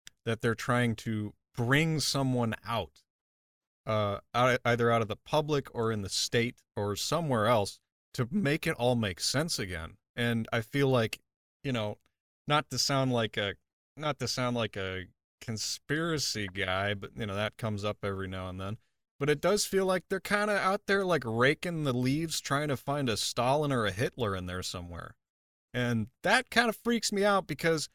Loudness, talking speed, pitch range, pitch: -30 LUFS, 190 wpm, 105-145 Hz, 120 Hz